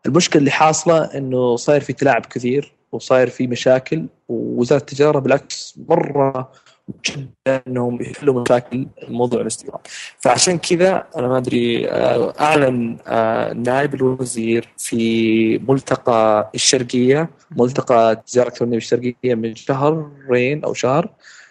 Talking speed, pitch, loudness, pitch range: 120 wpm, 130 Hz, -17 LUFS, 120-140 Hz